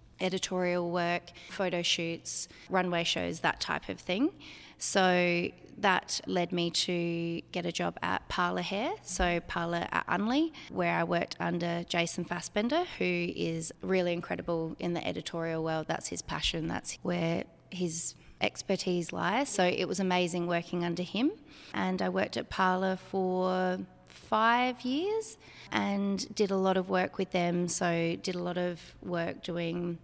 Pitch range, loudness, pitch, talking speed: 170-190 Hz, -31 LUFS, 180 Hz, 155 wpm